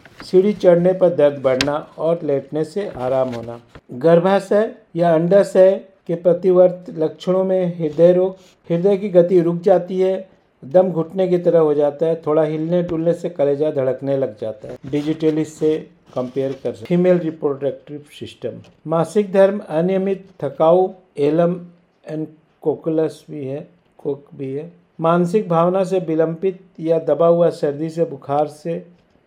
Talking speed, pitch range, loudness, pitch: 145 wpm, 150-185 Hz, -18 LUFS, 170 Hz